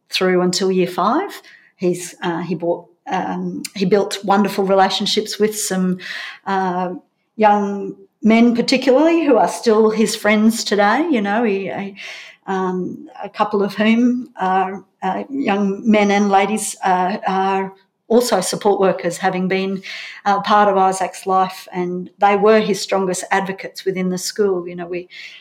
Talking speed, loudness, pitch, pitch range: 150 wpm, -17 LUFS, 195 Hz, 185-210 Hz